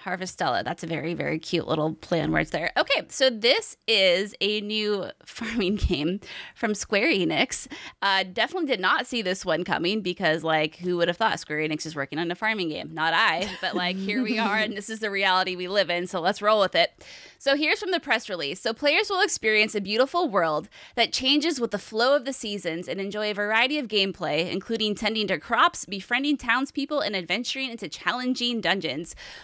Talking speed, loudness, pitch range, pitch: 205 wpm, -25 LUFS, 180-240 Hz, 210 Hz